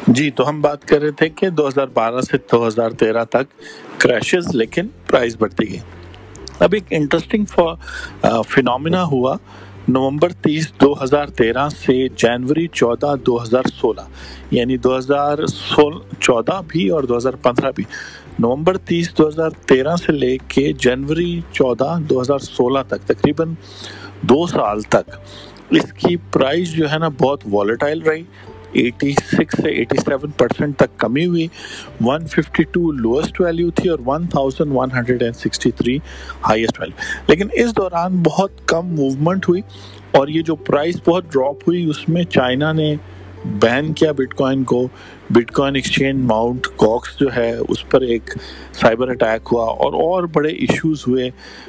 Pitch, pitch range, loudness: 140 Hz, 120-165 Hz, -17 LUFS